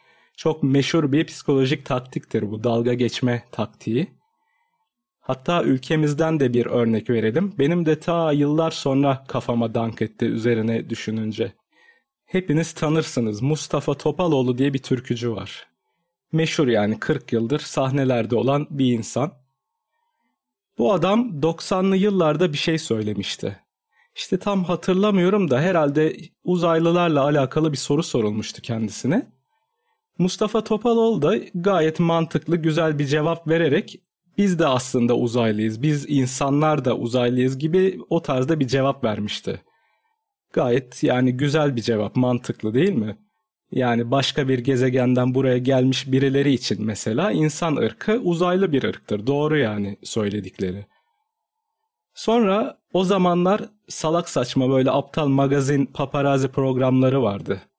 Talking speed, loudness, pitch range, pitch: 125 wpm, -21 LUFS, 125-175 Hz, 145 Hz